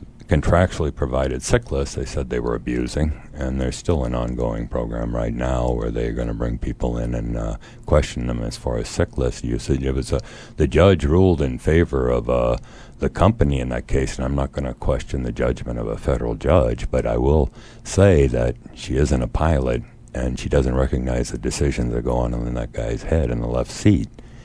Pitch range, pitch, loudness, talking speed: 60-75 Hz, 65 Hz, -22 LUFS, 215 wpm